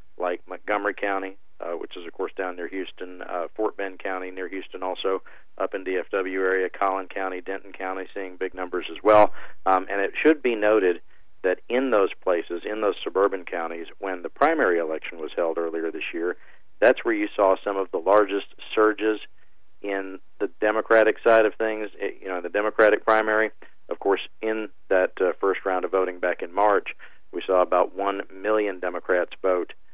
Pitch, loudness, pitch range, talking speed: 95 Hz, -24 LUFS, 95-105 Hz, 190 wpm